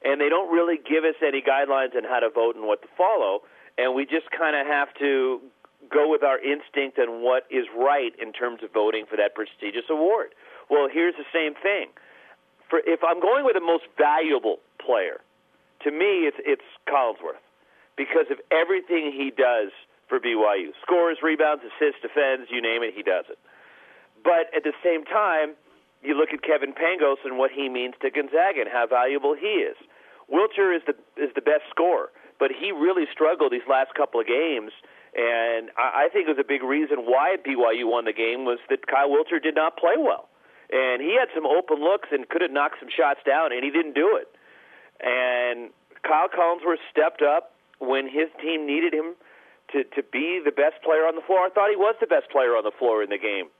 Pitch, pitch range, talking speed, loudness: 155 Hz, 135-200 Hz, 205 wpm, -23 LUFS